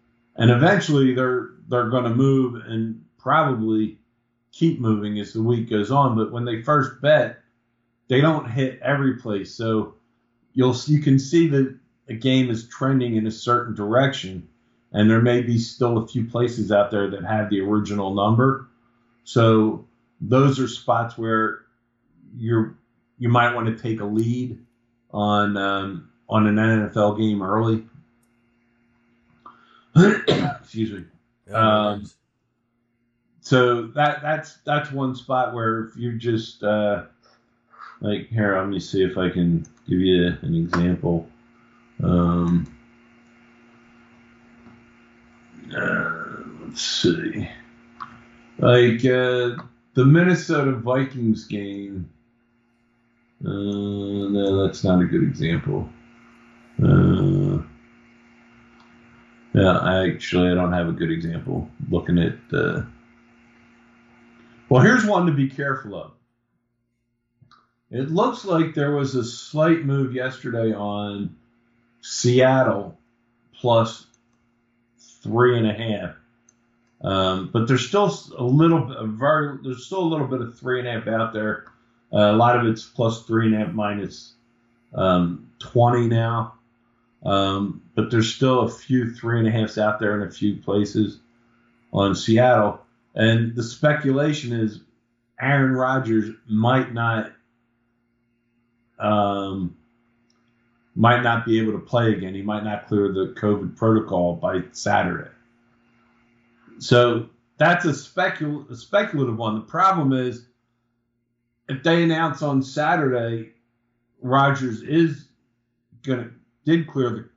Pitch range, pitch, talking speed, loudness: 110-125 Hz, 120 Hz, 130 wpm, -21 LUFS